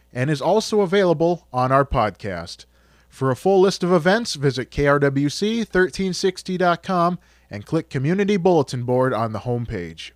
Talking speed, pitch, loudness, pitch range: 135 wpm, 150 Hz, -20 LUFS, 125-185 Hz